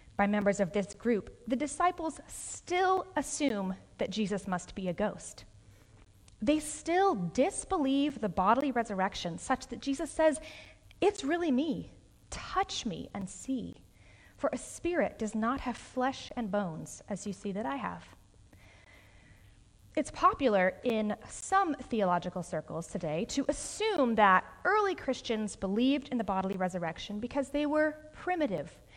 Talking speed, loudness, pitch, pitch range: 140 wpm, -32 LUFS, 225 Hz, 185-290 Hz